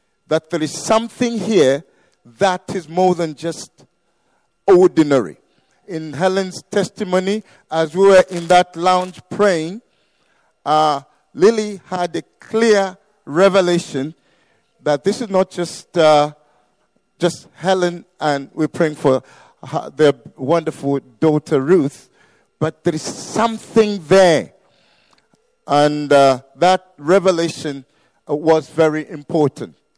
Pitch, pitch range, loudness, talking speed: 170 Hz, 150-190 Hz, -17 LUFS, 110 wpm